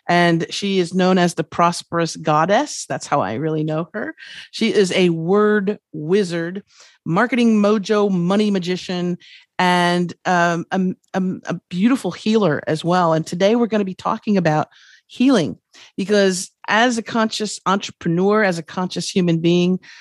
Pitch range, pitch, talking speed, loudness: 170-210 Hz, 185 Hz, 155 wpm, -19 LUFS